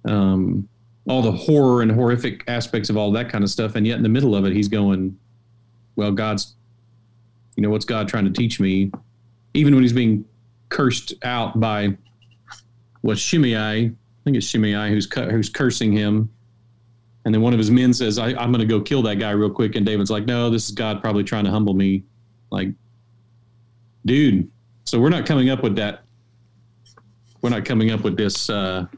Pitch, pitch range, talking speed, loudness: 115 Hz, 105-115 Hz, 195 wpm, -20 LUFS